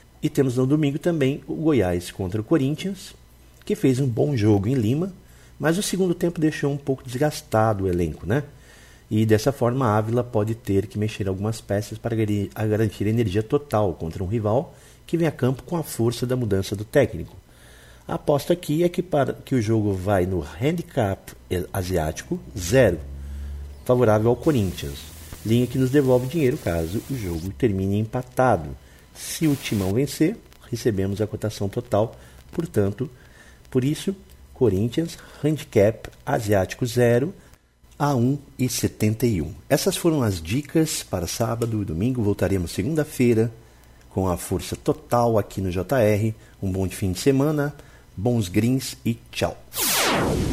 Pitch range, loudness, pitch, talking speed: 95-140 Hz, -23 LUFS, 115 Hz, 150 wpm